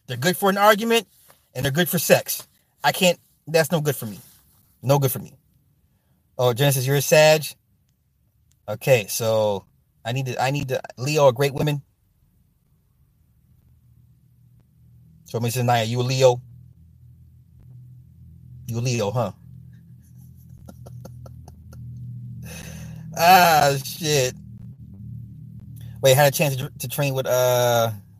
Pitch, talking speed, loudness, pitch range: 125 Hz, 125 wpm, -20 LUFS, 120-145 Hz